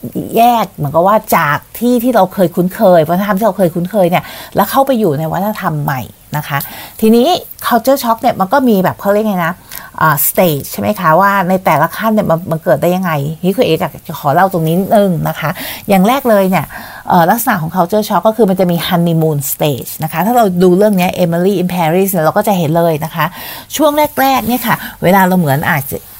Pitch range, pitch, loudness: 160-215 Hz, 180 Hz, -12 LUFS